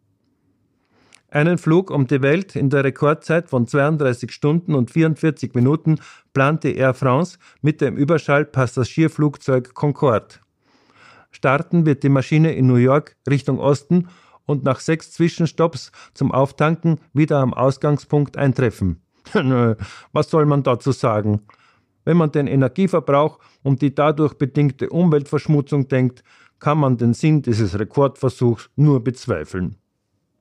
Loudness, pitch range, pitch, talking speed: -19 LUFS, 130-155 Hz, 140 Hz, 130 wpm